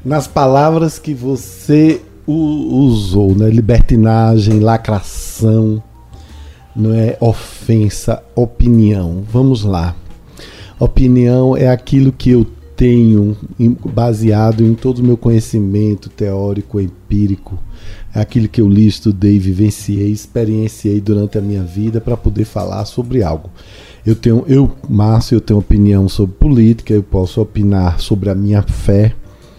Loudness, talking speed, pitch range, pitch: -13 LUFS, 120 wpm, 100-120 Hz, 110 Hz